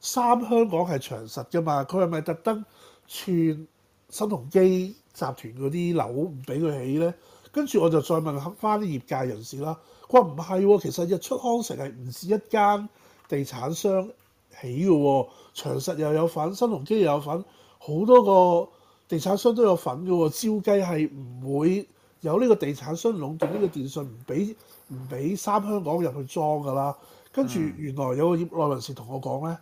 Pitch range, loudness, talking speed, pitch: 140-200 Hz, -25 LUFS, 265 characters per minute, 165 Hz